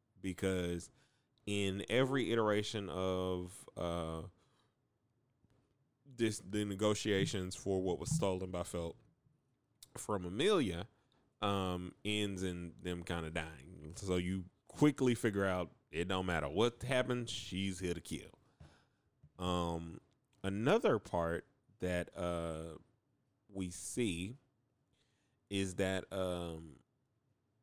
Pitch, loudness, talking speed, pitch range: 95 Hz, -38 LUFS, 105 wpm, 90-115 Hz